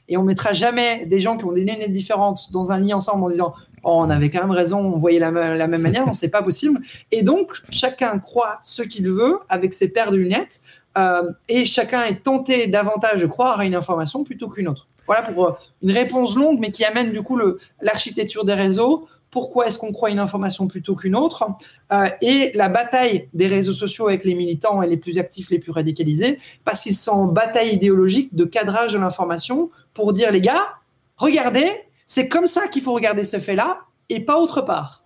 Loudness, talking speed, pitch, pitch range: -19 LUFS, 210 wpm, 205 Hz, 185-240 Hz